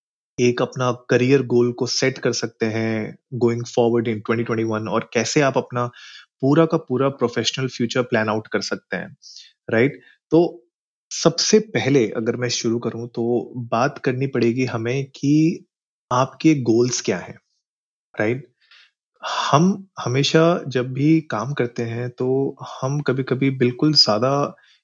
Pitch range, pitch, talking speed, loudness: 120-140 Hz, 125 Hz, 145 wpm, -20 LUFS